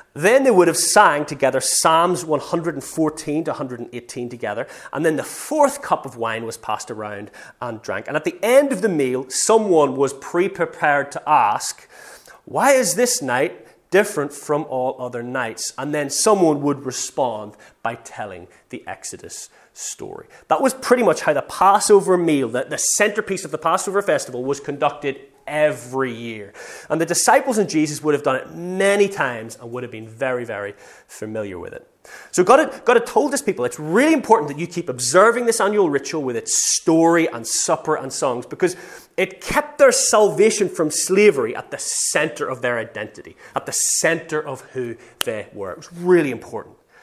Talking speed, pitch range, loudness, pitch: 180 wpm, 140-210 Hz, -19 LUFS, 165 Hz